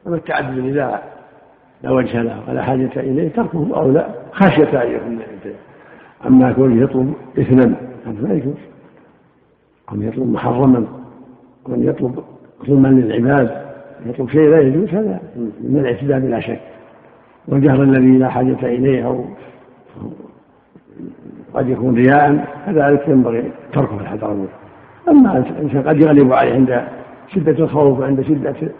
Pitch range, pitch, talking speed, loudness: 125-145 Hz, 130 Hz, 125 wpm, -15 LUFS